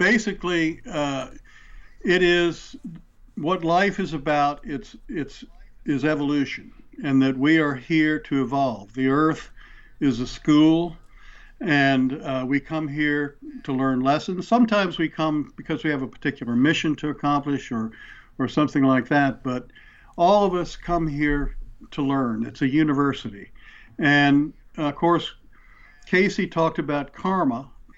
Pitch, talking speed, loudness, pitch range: 150 Hz, 145 wpm, -23 LUFS, 140-170 Hz